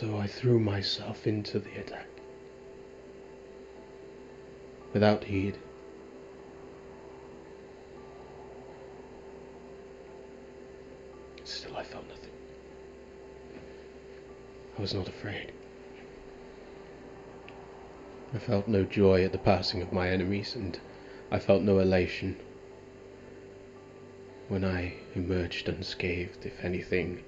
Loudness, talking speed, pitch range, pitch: -30 LUFS, 85 wpm, 65-100 Hz, 95 Hz